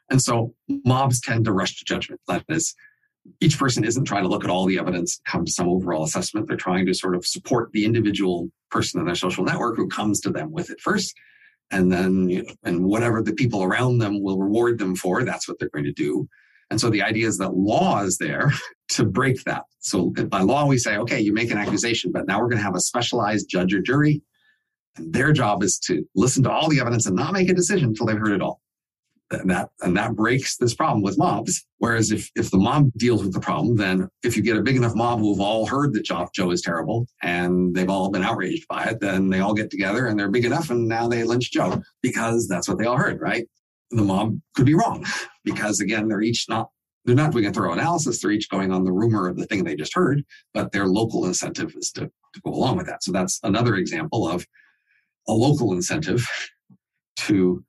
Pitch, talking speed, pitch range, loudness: 110 Hz, 235 wpm, 95-120 Hz, -22 LUFS